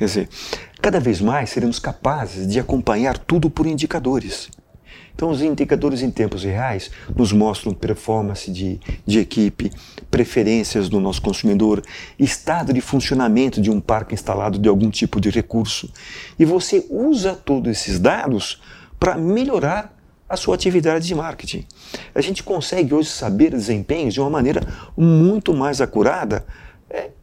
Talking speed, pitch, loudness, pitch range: 145 wpm, 130 Hz, -19 LUFS, 105-160 Hz